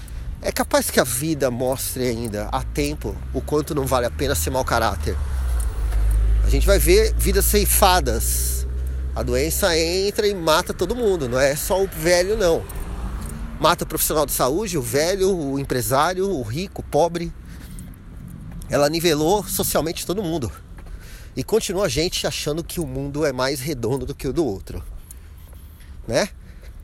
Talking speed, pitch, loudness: 160 wpm, 135 Hz, -21 LUFS